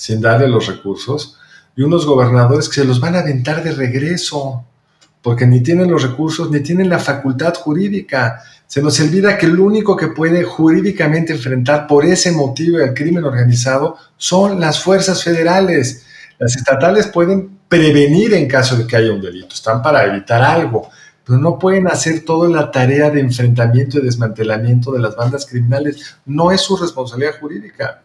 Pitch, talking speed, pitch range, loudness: 145 Hz, 170 wpm, 130-170 Hz, -13 LUFS